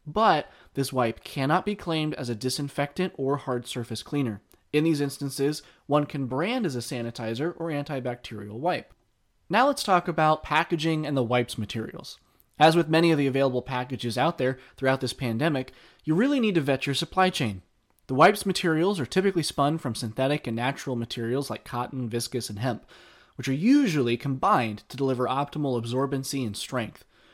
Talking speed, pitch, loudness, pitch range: 175 wpm, 135 Hz, -26 LUFS, 125-160 Hz